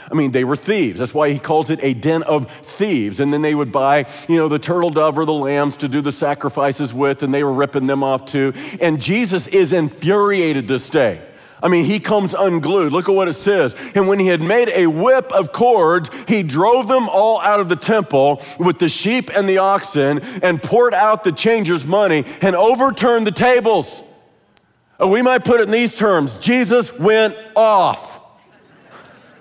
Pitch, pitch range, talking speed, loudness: 175 Hz, 145-210 Hz, 200 wpm, -16 LUFS